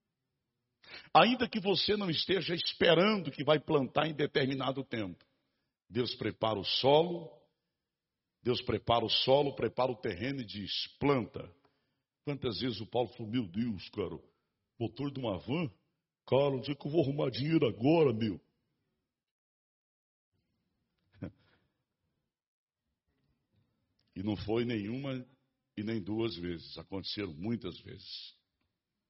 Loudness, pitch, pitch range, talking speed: -32 LUFS, 125 Hz, 110-140 Hz, 120 wpm